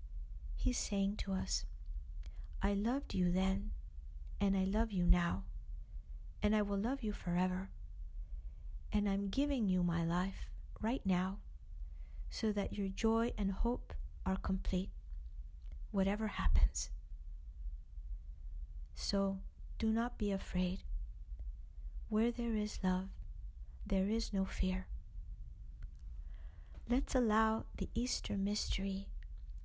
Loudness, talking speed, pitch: -37 LUFS, 110 wpm, 185 Hz